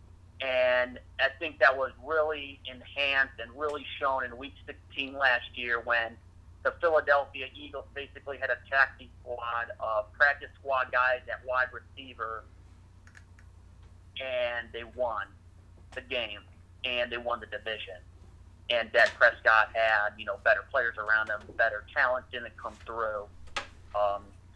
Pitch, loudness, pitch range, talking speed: 110 Hz, -29 LUFS, 90-130 Hz, 140 wpm